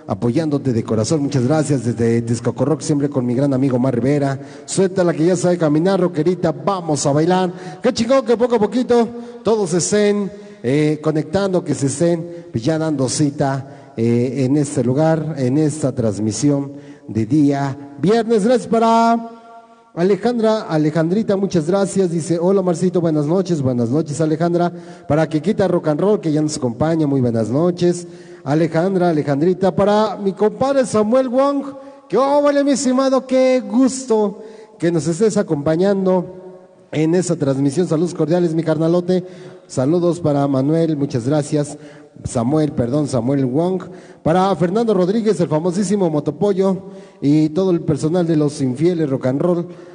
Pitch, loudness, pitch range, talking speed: 170 Hz, -17 LUFS, 145-195 Hz, 155 wpm